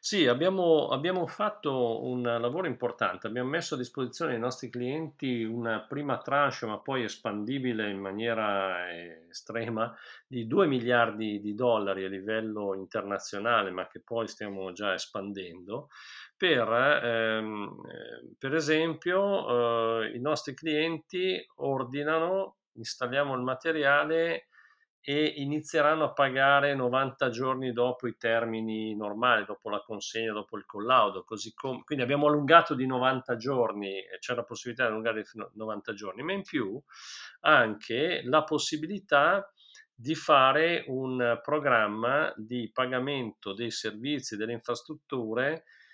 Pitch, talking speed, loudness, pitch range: 125 Hz, 130 wpm, -29 LUFS, 115-150 Hz